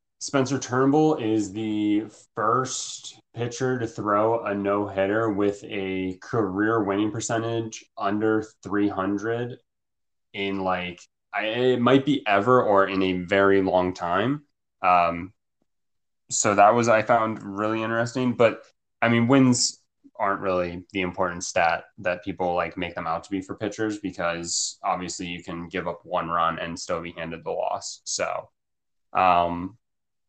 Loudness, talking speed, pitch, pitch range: -24 LUFS, 145 wpm, 100 Hz, 90-115 Hz